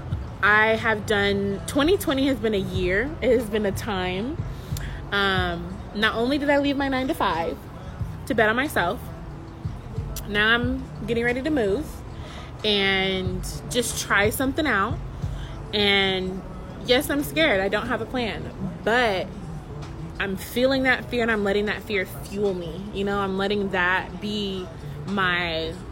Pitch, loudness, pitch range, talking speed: 205 Hz, -24 LUFS, 190-245 Hz, 155 wpm